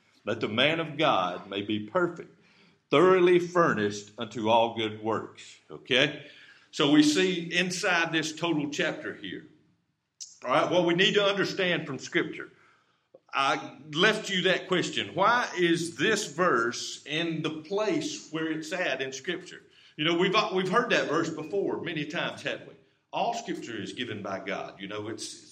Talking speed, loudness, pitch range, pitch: 165 wpm, -27 LUFS, 150-185 Hz, 165 Hz